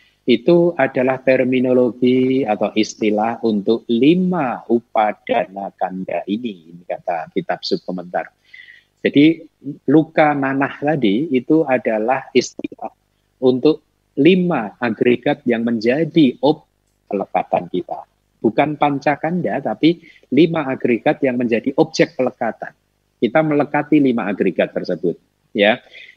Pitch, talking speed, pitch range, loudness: 130 Hz, 100 wpm, 120-155 Hz, -18 LUFS